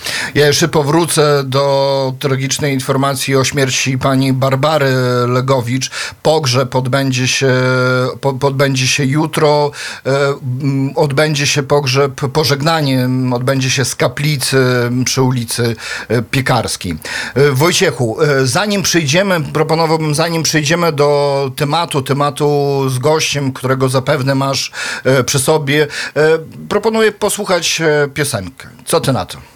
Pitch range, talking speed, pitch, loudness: 130-150 Hz, 105 wpm, 140 Hz, -14 LUFS